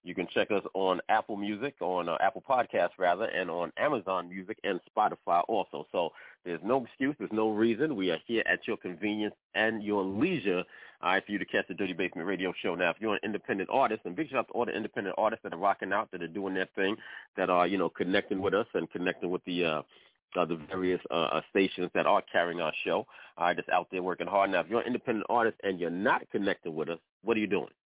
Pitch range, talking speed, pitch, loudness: 90-105 Hz, 245 wpm, 95 Hz, -31 LUFS